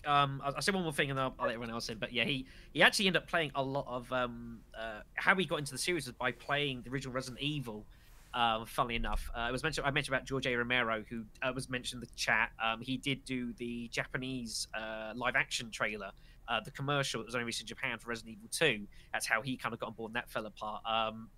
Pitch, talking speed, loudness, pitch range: 125 Hz, 265 wpm, -35 LUFS, 115-135 Hz